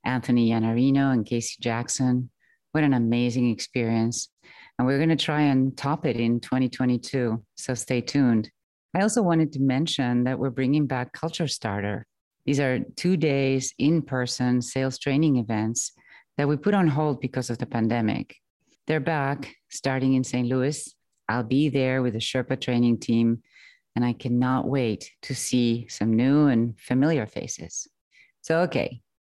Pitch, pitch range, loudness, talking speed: 130 Hz, 120-140 Hz, -25 LUFS, 160 wpm